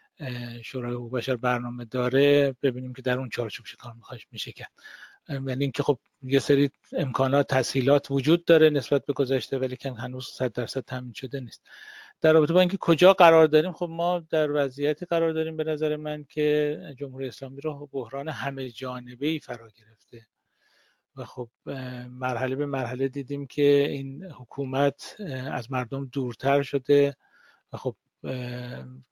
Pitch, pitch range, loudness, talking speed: 135 Hz, 125-145 Hz, -26 LUFS, 155 wpm